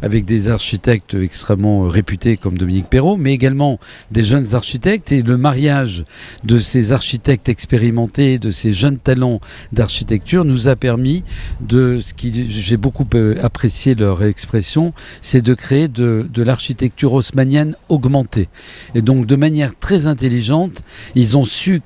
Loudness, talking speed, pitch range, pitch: -15 LUFS, 145 wpm, 110-140 Hz, 125 Hz